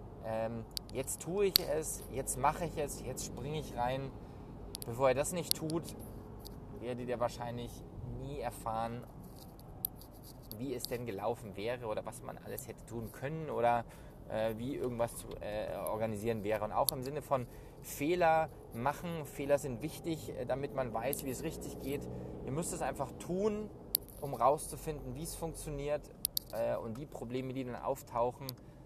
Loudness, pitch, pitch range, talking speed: -37 LUFS, 125 Hz, 115-145 Hz, 160 wpm